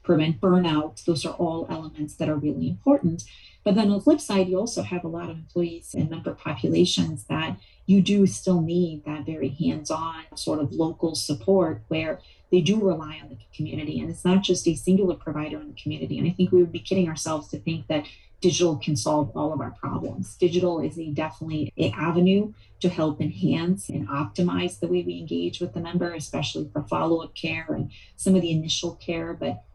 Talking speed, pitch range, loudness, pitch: 205 wpm, 150-180 Hz, -25 LUFS, 165 Hz